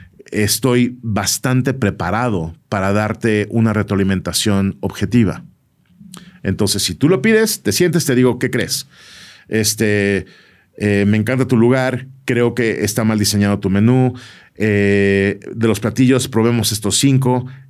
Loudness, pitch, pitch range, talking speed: -16 LUFS, 110 Hz, 100-125 Hz, 130 wpm